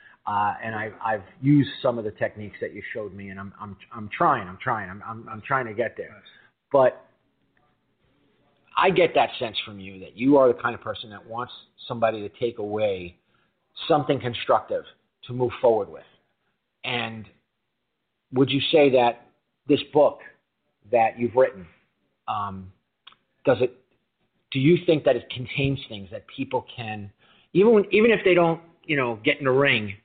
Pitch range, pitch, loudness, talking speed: 105-140 Hz, 120 Hz, -23 LUFS, 175 wpm